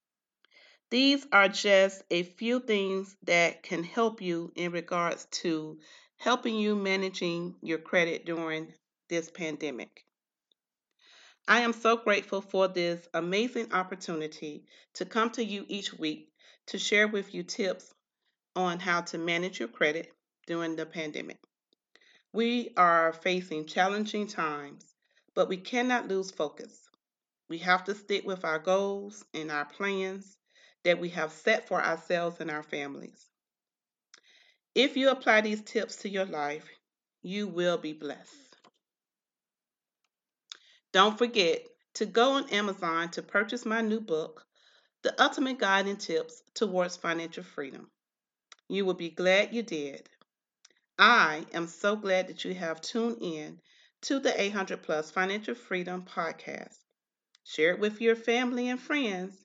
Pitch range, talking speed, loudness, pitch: 170-220 Hz, 140 wpm, -29 LUFS, 190 Hz